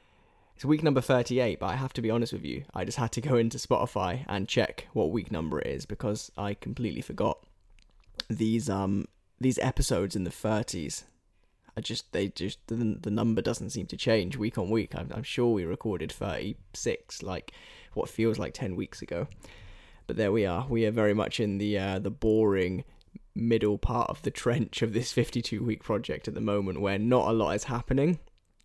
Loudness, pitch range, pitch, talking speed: -30 LUFS, 100-120 Hz, 110 Hz, 200 wpm